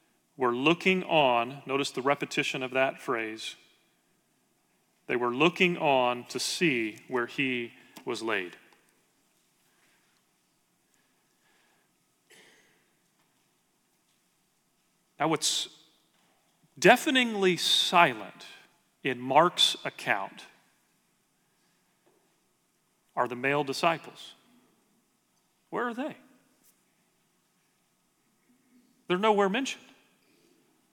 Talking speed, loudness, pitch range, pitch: 70 wpm, -27 LUFS, 130-190 Hz, 150 Hz